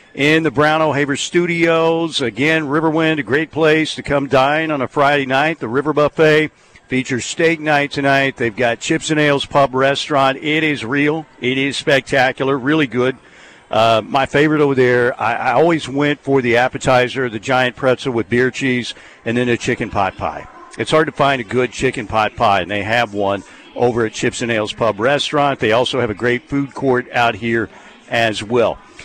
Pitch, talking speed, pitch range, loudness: 135 Hz, 195 wpm, 120-150 Hz, -16 LUFS